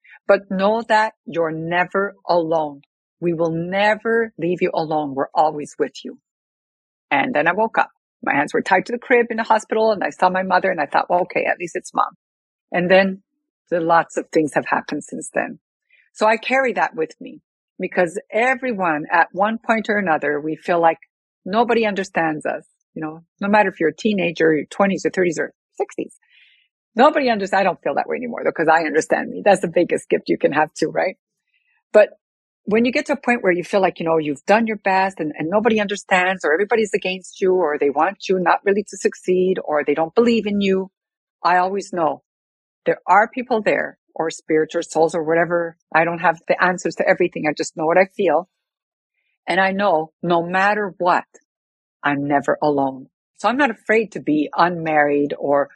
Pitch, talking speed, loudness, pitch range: 185 Hz, 205 wpm, -19 LUFS, 165-215 Hz